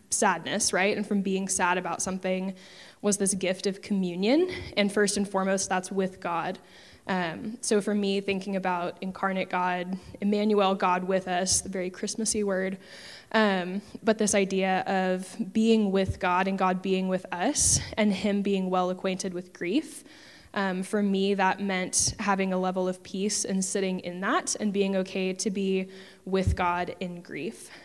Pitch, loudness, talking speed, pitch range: 190 Hz, -27 LUFS, 170 wpm, 185-205 Hz